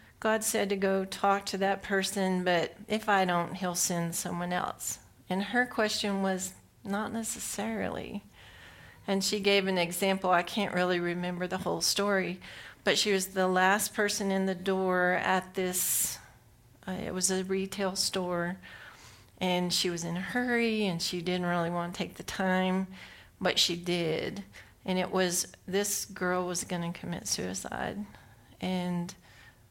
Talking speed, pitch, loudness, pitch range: 160 wpm, 185 Hz, -30 LUFS, 180-200 Hz